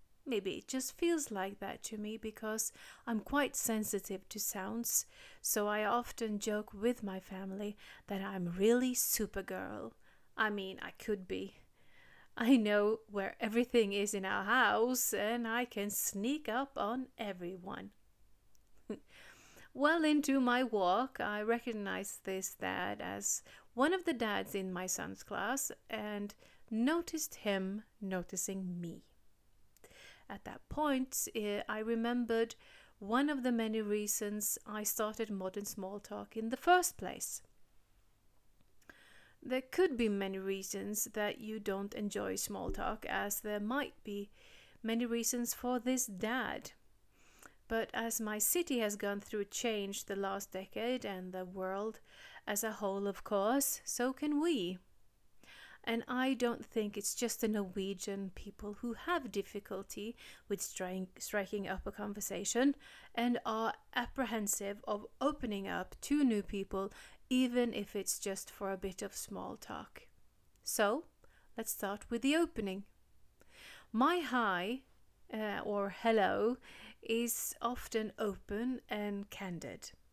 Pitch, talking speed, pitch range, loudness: 215 Hz, 135 wpm, 200-245 Hz, -37 LUFS